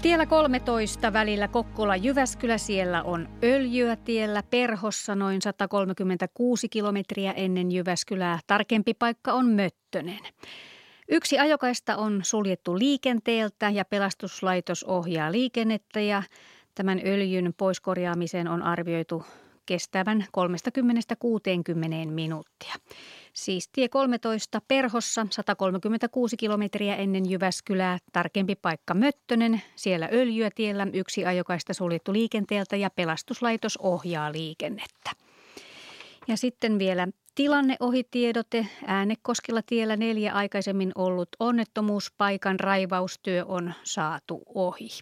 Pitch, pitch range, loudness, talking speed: 205 Hz, 185-230 Hz, -27 LUFS, 95 wpm